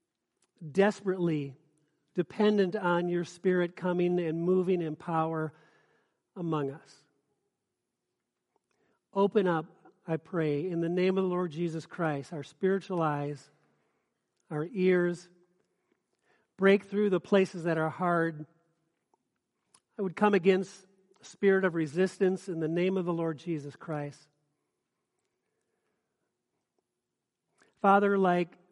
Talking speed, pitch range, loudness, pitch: 115 wpm, 160-190 Hz, -30 LUFS, 175 Hz